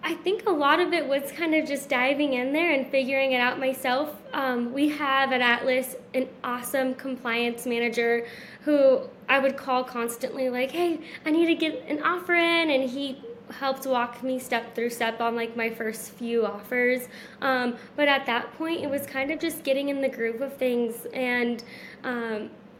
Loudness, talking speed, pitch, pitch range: -26 LUFS, 190 wpm, 260 Hz, 240-280 Hz